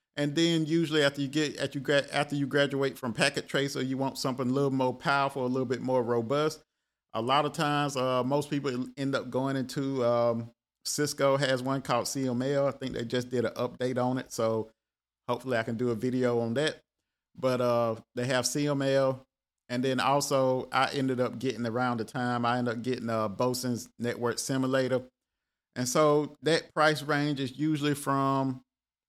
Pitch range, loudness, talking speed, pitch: 125-140 Hz, -29 LUFS, 185 wpm, 130 Hz